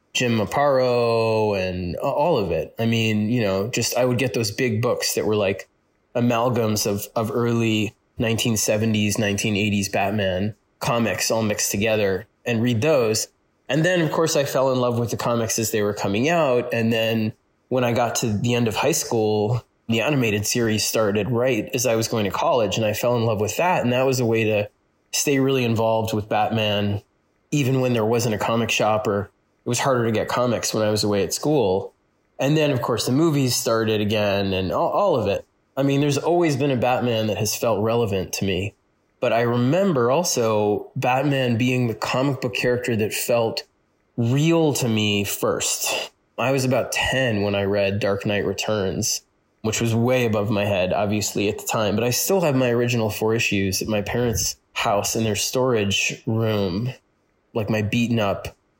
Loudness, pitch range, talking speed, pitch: -21 LUFS, 105-125 Hz, 195 wpm, 115 Hz